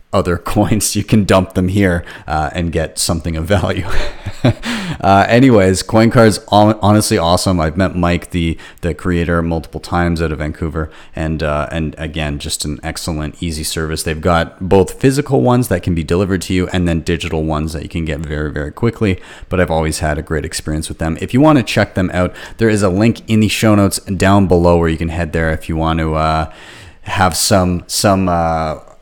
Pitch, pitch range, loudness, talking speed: 85 Hz, 80-100 Hz, -15 LUFS, 210 wpm